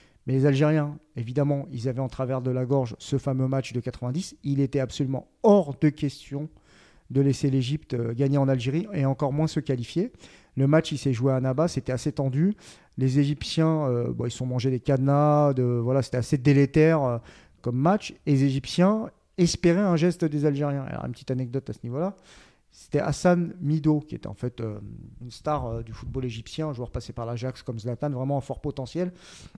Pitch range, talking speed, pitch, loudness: 125-150 Hz, 205 wpm, 140 Hz, -26 LUFS